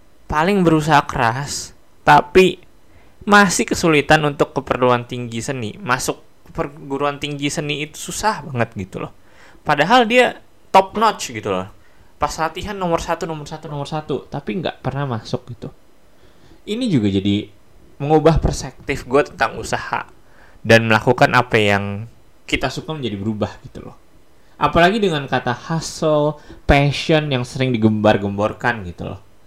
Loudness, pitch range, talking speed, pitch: -18 LUFS, 110-155 Hz, 135 wpm, 140 Hz